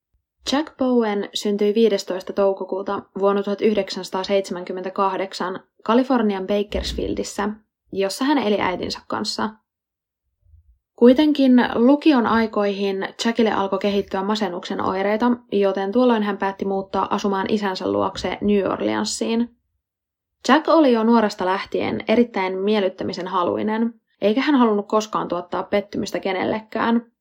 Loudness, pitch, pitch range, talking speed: -21 LUFS, 200 Hz, 190-230 Hz, 105 wpm